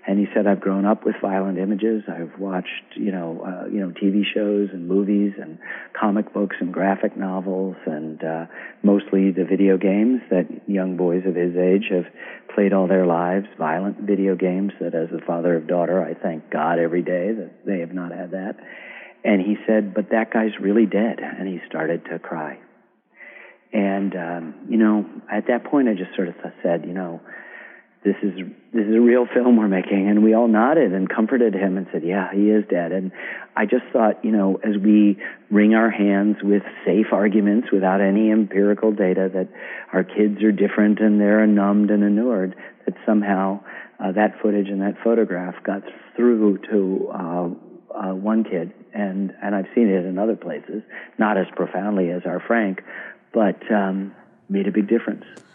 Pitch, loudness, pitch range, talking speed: 100 Hz, -21 LUFS, 95-105 Hz, 190 wpm